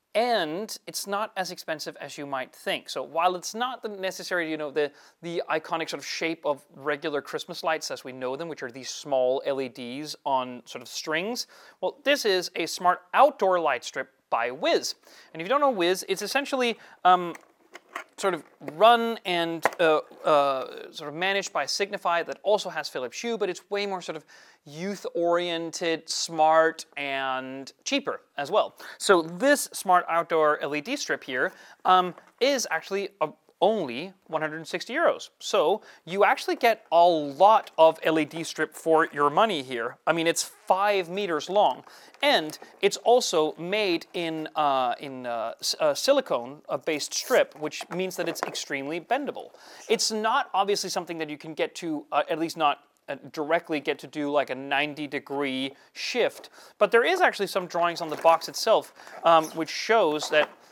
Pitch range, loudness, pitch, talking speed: 150-205 Hz, -26 LUFS, 170 Hz, 170 wpm